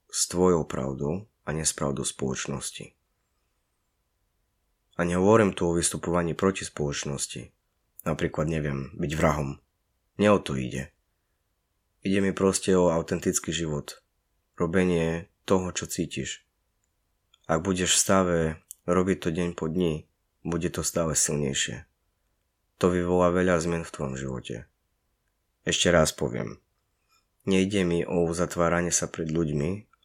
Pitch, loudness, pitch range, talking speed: 85 Hz, -26 LUFS, 75-90 Hz, 120 wpm